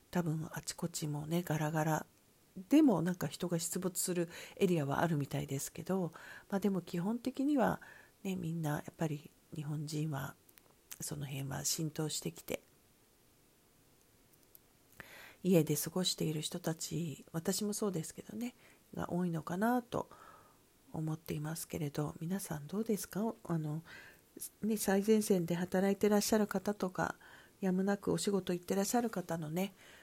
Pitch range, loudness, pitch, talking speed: 155-195 Hz, -36 LUFS, 175 Hz, 295 characters per minute